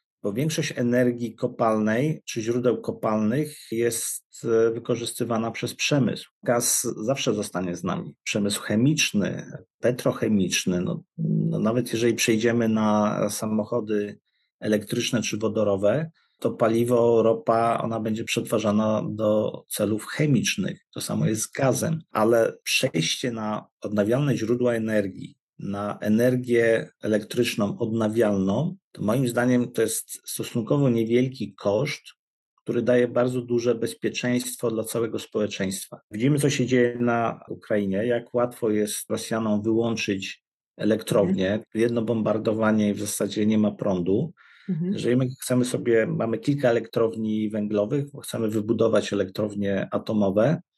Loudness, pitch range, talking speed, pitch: -24 LUFS, 105-120 Hz, 120 wpm, 115 Hz